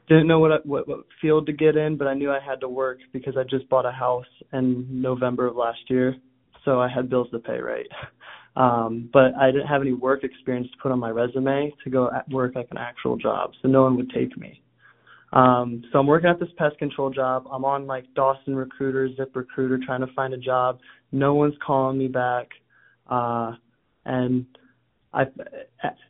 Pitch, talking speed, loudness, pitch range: 130 Hz, 210 wpm, -23 LUFS, 125-135 Hz